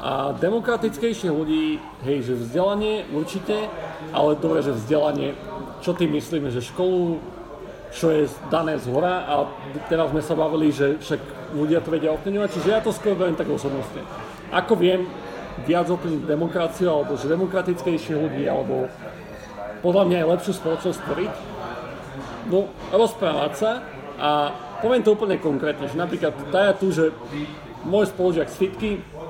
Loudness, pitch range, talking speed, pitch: -23 LUFS, 150-185 Hz, 145 wpm, 165 Hz